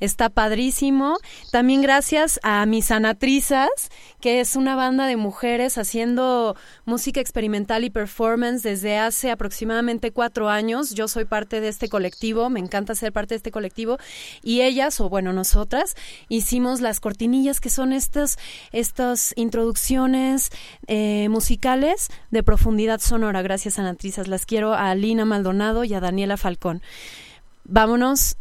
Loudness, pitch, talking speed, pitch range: -21 LUFS, 230 Hz, 140 wpm, 215-255 Hz